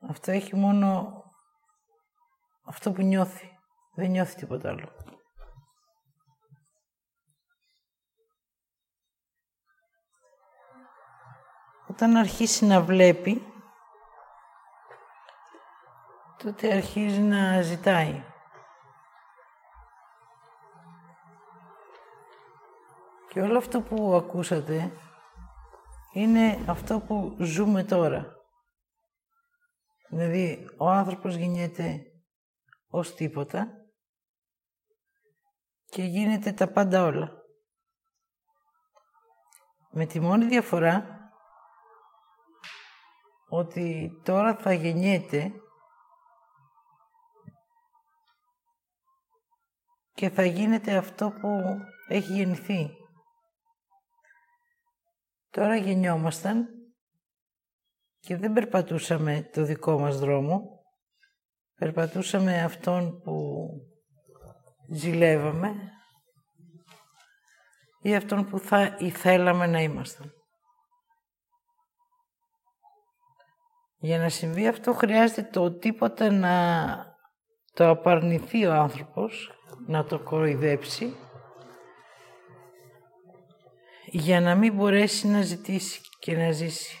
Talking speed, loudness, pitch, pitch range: 70 wpm, -26 LUFS, 195 Hz, 165-245 Hz